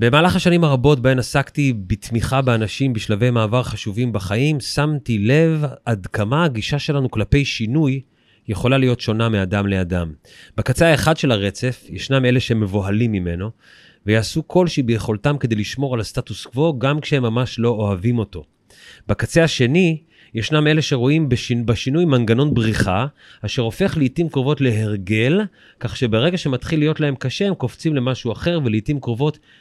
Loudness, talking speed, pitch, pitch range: -19 LUFS, 145 wpm, 125 Hz, 110-145 Hz